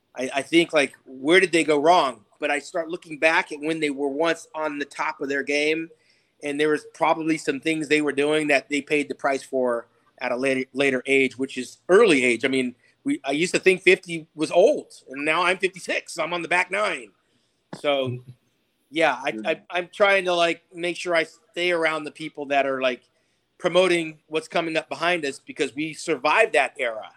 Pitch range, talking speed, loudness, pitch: 140-170 Hz, 215 wpm, -23 LUFS, 155 Hz